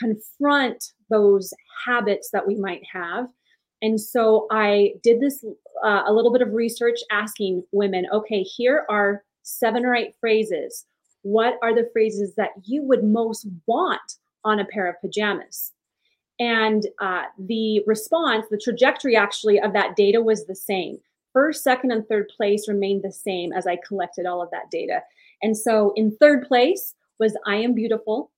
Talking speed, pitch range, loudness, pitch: 165 wpm, 205-235 Hz, -22 LUFS, 215 Hz